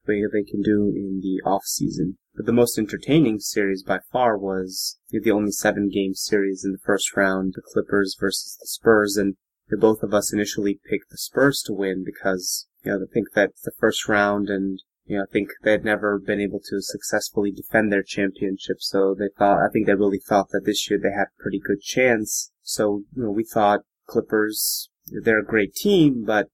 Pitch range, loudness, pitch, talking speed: 100-105 Hz, -22 LUFS, 100 Hz, 210 wpm